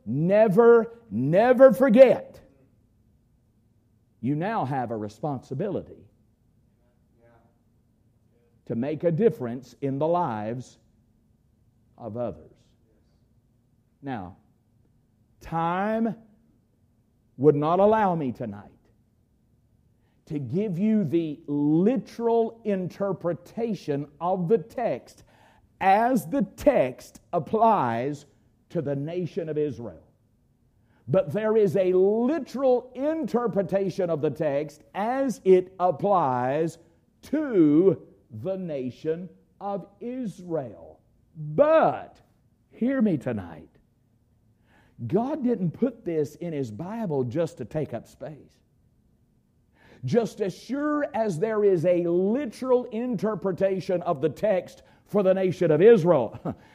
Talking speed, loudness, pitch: 95 wpm, -25 LUFS, 160 Hz